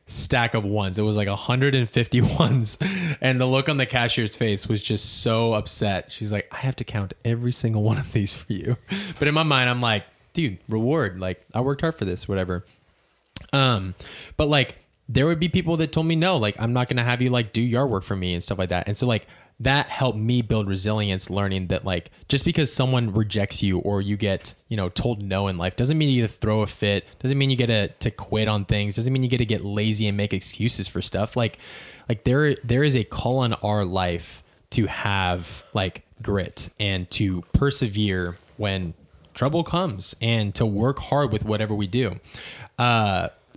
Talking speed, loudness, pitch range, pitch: 215 wpm, -23 LUFS, 100-130 Hz, 110 Hz